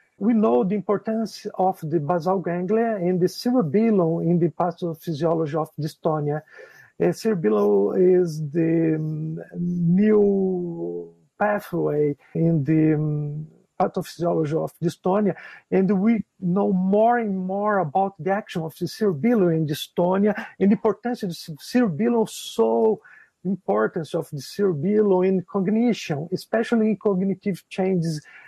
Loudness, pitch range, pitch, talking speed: -23 LUFS, 165-205 Hz, 185 Hz, 120 wpm